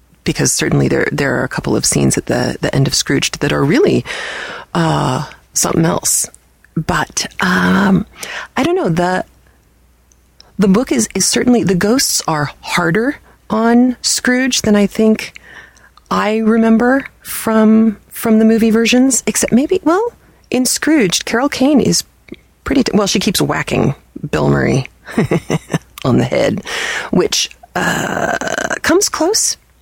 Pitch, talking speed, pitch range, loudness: 220 Hz, 145 wpm, 195-250 Hz, -14 LUFS